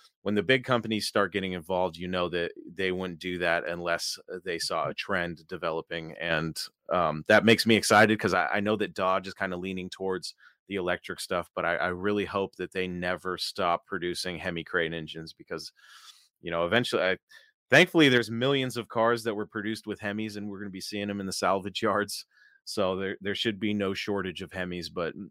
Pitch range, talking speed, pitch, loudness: 90-105 Hz, 210 wpm, 95 Hz, -28 LUFS